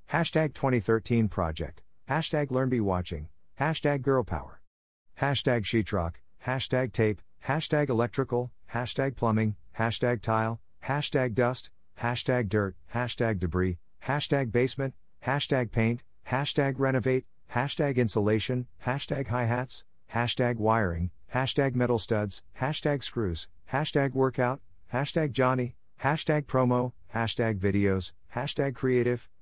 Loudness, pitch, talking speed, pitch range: -29 LUFS, 125 Hz, 110 wpm, 110-135 Hz